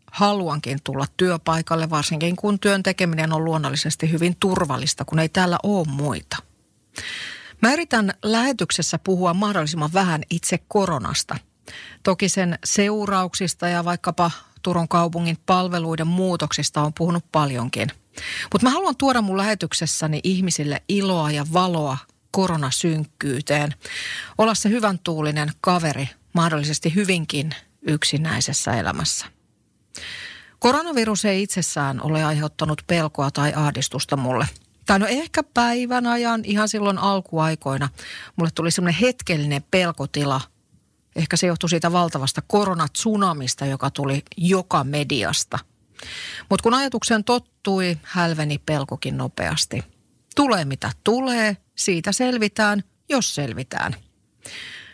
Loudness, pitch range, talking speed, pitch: -22 LUFS, 150-195 Hz, 110 wpm, 170 Hz